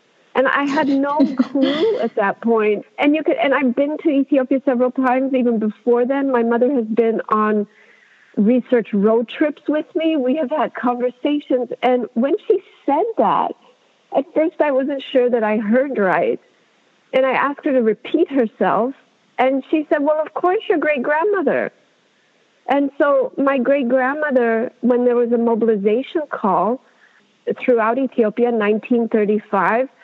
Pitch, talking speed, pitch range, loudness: 260 Hz, 155 wpm, 230-290 Hz, -18 LUFS